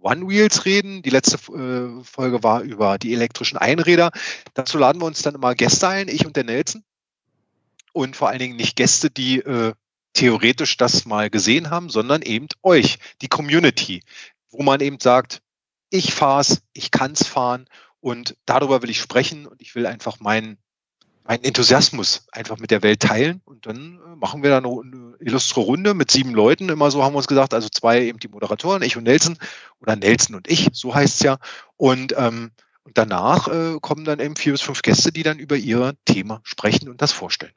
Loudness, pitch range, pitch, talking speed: -18 LUFS, 115-150 Hz, 130 Hz, 200 wpm